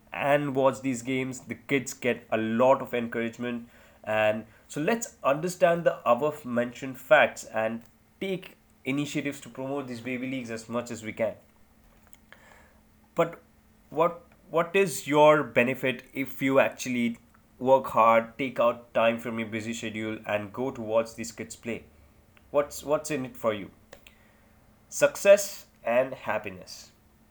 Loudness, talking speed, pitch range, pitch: -27 LUFS, 145 wpm, 115-140 Hz, 125 Hz